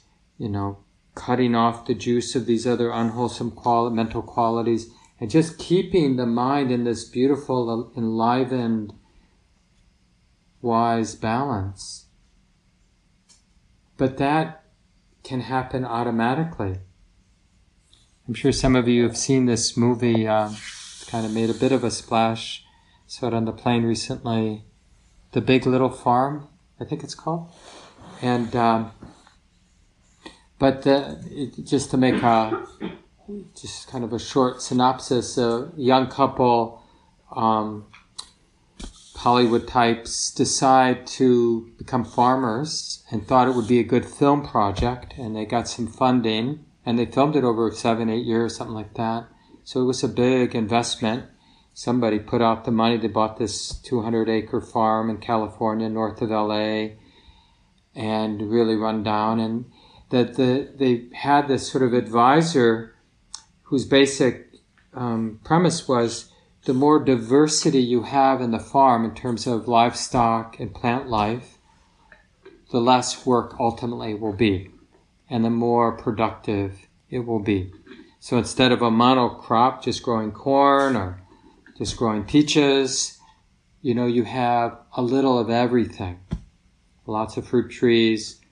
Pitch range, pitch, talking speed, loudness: 110-130 Hz, 120 Hz, 140 wpm, -22 LUFS